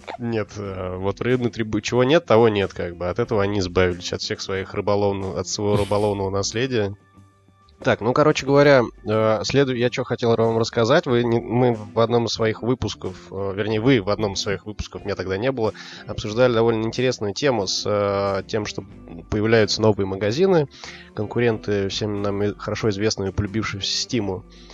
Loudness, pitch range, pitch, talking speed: -21 LUFS, 100-115 Hz, 105 Hz, 165 wpm